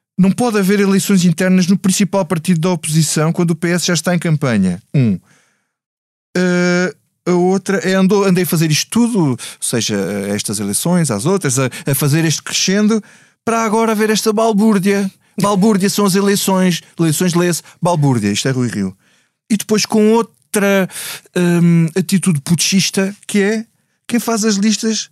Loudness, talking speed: -15 LUFS, 160 wpm